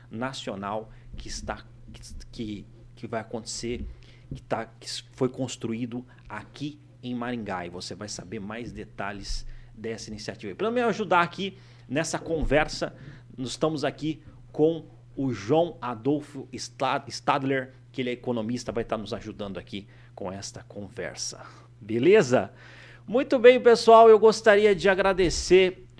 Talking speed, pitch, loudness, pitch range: 130 wpm, 125 Hz, -25 LUFS, 115-145 Hz